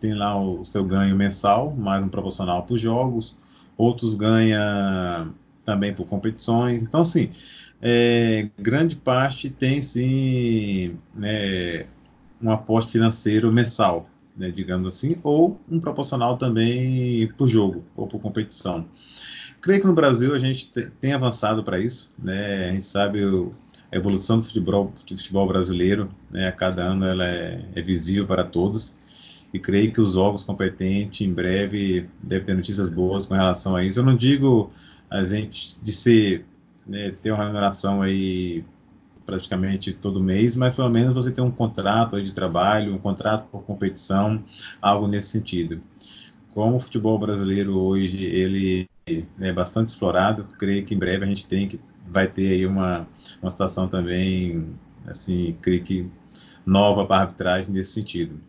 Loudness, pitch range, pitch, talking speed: -22 LUFS, 95-115 Hz, 100 Hz, 155 wpm